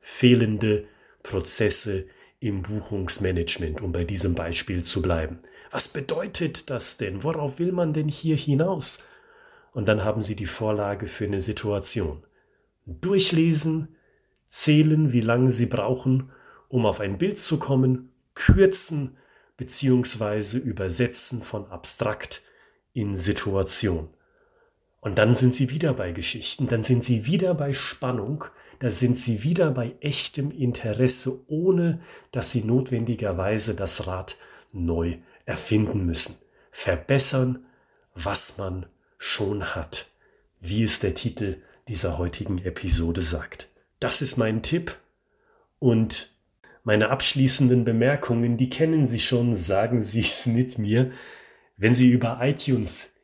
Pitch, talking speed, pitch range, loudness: 120 Hz, 125 wpm, 100-135 Hz, -19 LUFS